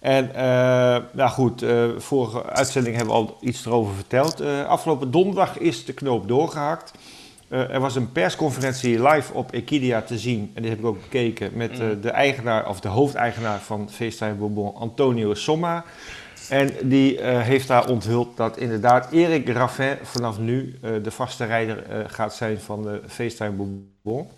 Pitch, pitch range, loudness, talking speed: 120 Hz, 110-135 Hz, -22 LUFS, 175 wpm